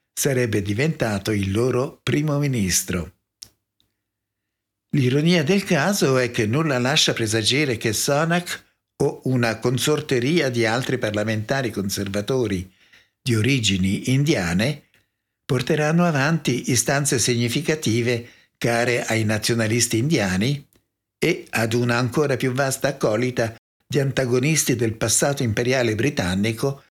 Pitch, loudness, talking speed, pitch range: 125 Hz, -21 LUFS, 105 wpm, 110-140 Hz